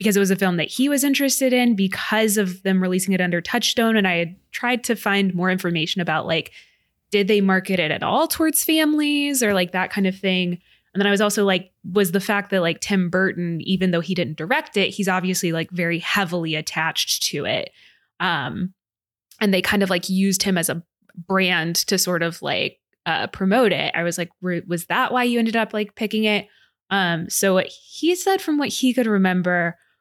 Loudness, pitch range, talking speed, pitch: -20 LUFS, 175-215 Hz, 215 wpm, 190 Hz